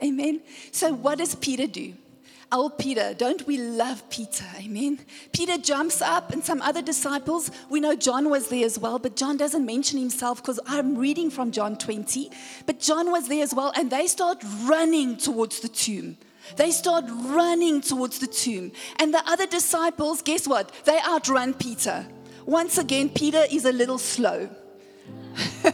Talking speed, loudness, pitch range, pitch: 170 wpm, -24 LUFS, 255-315 Hz, 285 Hz